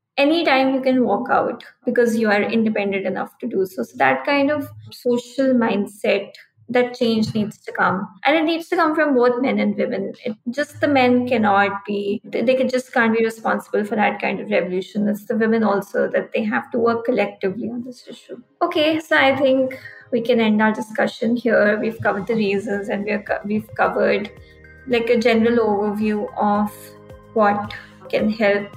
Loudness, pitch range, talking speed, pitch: -20 LUFS, 205-255 Hz, 190 wpm, 230 Hz